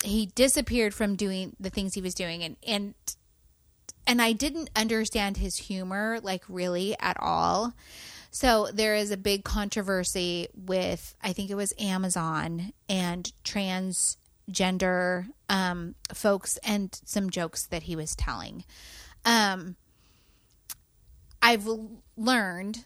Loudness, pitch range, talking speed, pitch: -28 LUFS, 185-220 Hz, 125 wpm, 200 Hz